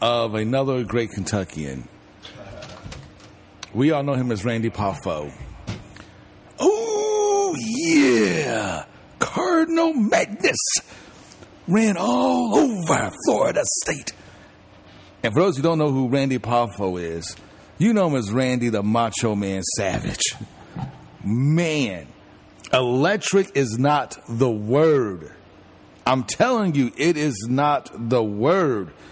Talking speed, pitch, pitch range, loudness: 110 wpm, 125 Hz, 105-155 Hz, -21 LUFS